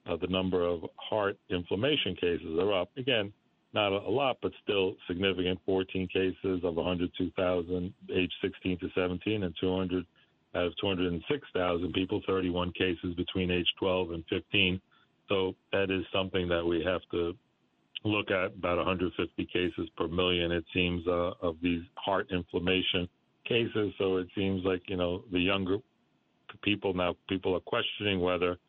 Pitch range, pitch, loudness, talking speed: 90-95 Hz, 90 Hz, -31 LUFS, 155 wpm